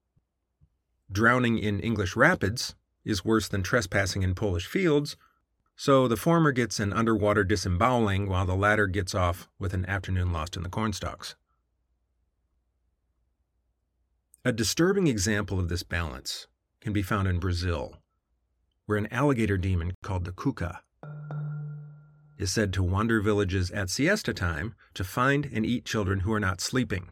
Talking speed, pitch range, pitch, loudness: 145 wpm, 90-115 Hz, 100 Hz, -27 LUFS